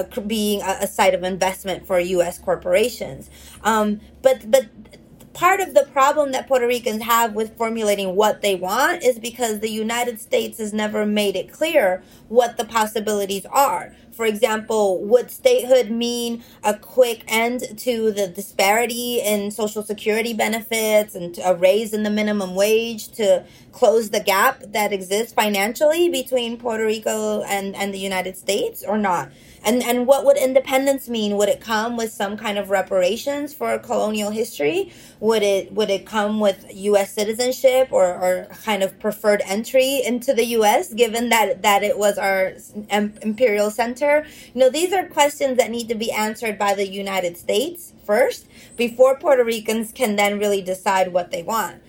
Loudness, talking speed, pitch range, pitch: -20 LUFS, 170 wpm, 205-250 Hz, 220 Hz